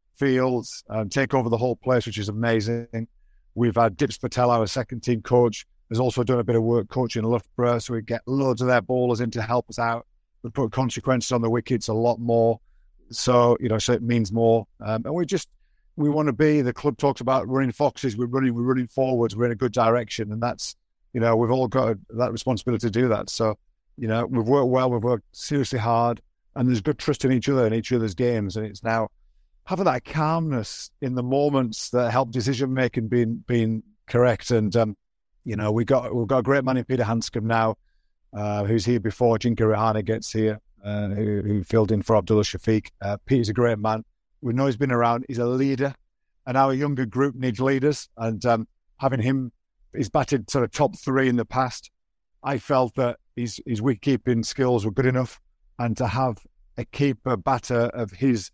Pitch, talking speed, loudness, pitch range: 120 Hz, 215 wpm, -24 LUFS, 115-130 Hz